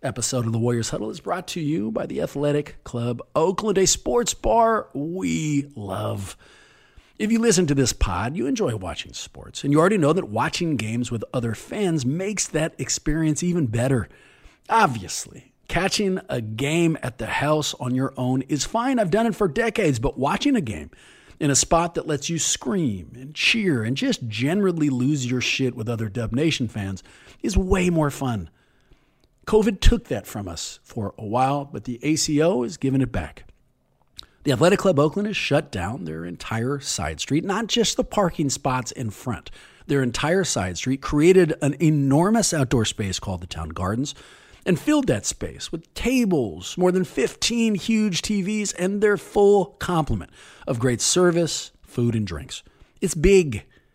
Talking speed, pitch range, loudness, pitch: 175 wpm, 120-185 Hz, -23 LUFS, 145 Hz